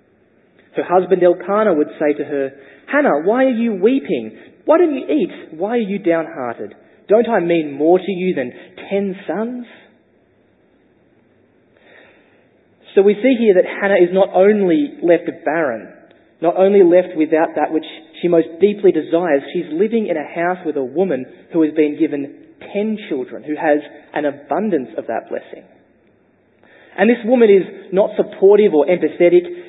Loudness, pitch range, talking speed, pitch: -16 LUFS, 155-205 Hz, 160 wpm, 180 Hz